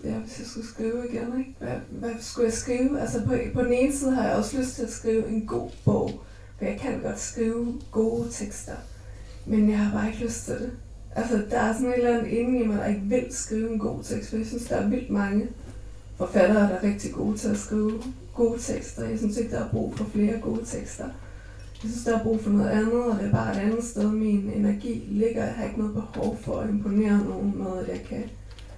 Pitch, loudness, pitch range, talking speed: 220 Hz, -27 LUFS, 205-235 Hz, 245 wpm